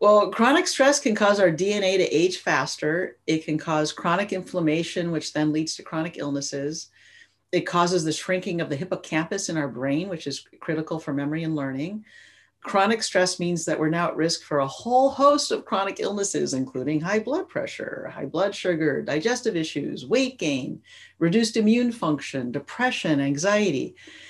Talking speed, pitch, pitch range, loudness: 170 wpm, 175 Hz, 155-215 Hz, -24 LUFS